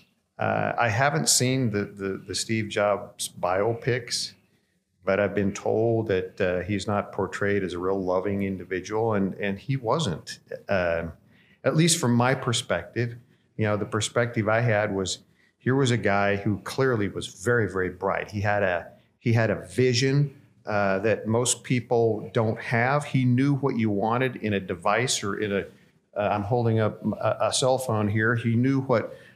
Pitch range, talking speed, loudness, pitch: 100-120 Hz, 180 wpm, -25 LUFS, 110 Hz